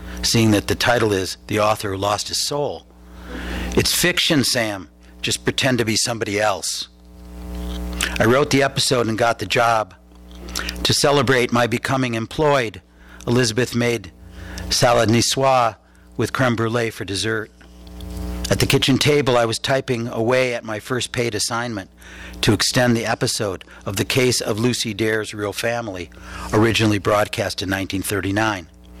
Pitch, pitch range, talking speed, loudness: 110 Hz, 90-120 Hz, 145 wpm, -19 LUFS